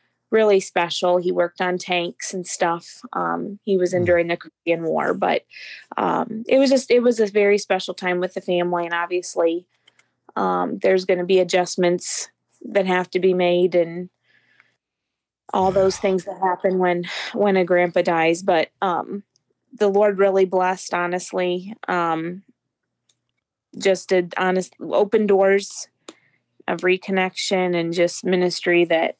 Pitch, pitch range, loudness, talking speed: 185 Hz, 175-195 Hz, -20 LUFS, 150 wpm